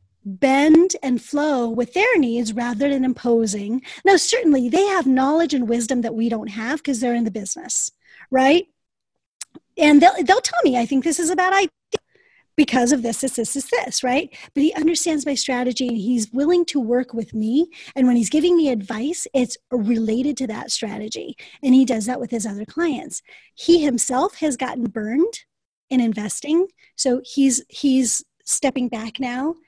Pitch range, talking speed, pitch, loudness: 240-320 Hz, 180 wpm, 265 Hz, -20 LUFS